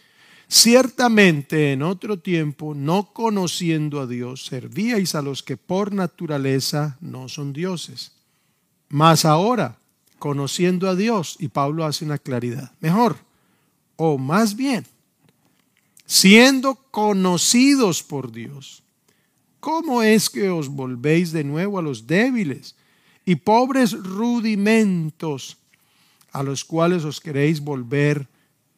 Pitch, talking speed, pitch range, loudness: 165 Hz, 115 wpm, 145-205 Hz, -19 LUFS